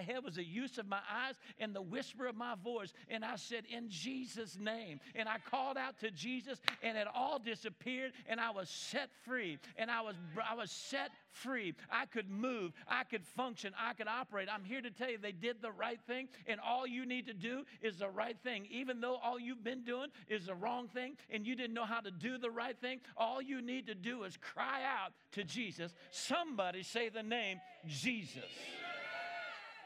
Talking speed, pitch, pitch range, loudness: 210 wpm, 235 Hz, 220-255 Hz, -42 LUFS